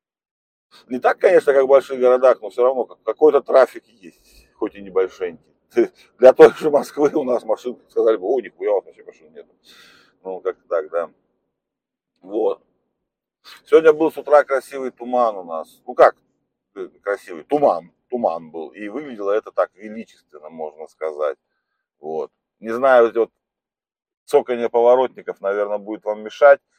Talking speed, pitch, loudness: 150 wpm, 140 Hz, -18 LUFS